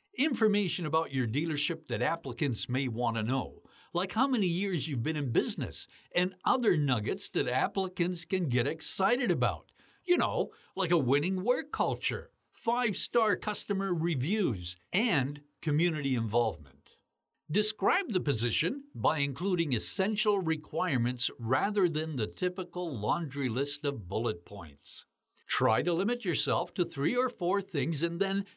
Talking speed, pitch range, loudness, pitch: 145 wpm, 135-195 Hz, -30 LUFS, 170 Hz